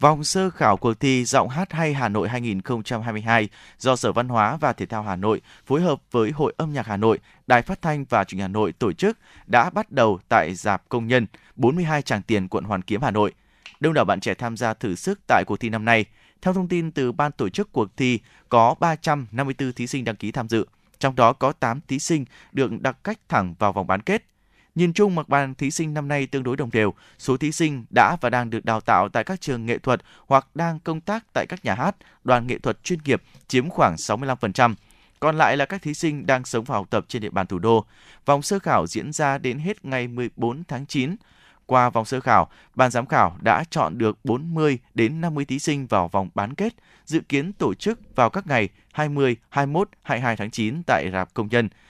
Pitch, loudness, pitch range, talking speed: 125 Hz, -23 LUFS, 110-150 Hz, 230 wpm